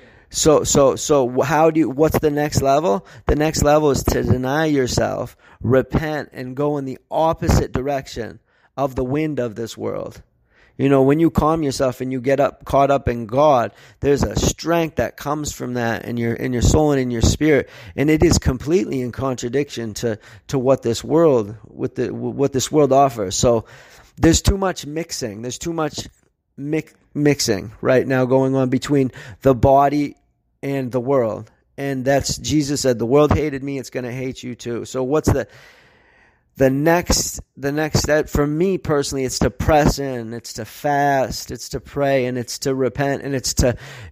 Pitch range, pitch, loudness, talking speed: 120-145 Hz, 135 Hz, -19 LUFS, 190 wpm